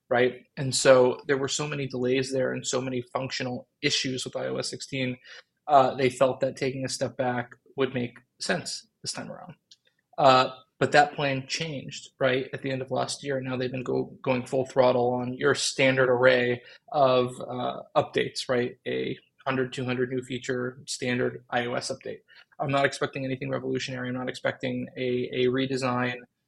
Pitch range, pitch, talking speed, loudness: 125-135 Hz, 130 Hz, 175 wpm, -27 LUFS